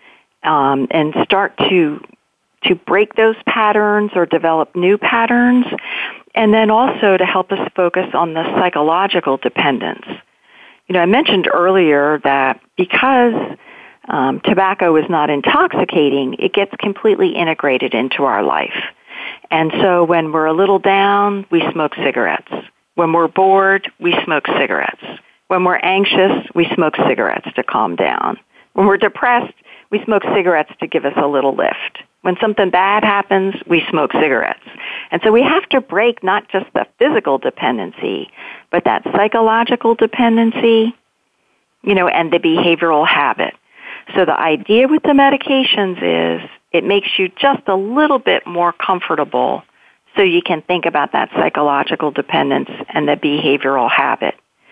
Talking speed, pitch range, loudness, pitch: 150 wpm, 165-225 Hz, -14 LUFS, 190 Hz